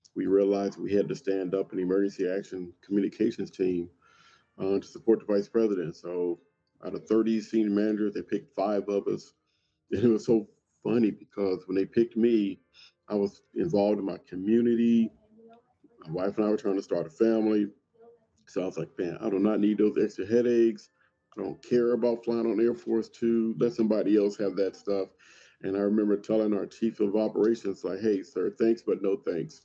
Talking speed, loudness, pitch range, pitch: 195 wpm, -28 LUFS, 100-115 Hz, 105 Hz